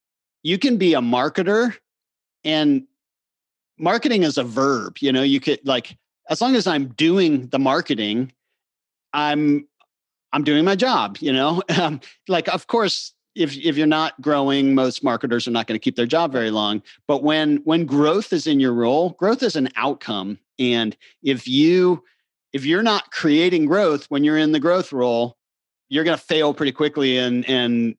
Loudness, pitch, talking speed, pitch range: -20 LUFS, 145 Hz, 175 wpm, 125-165 Hz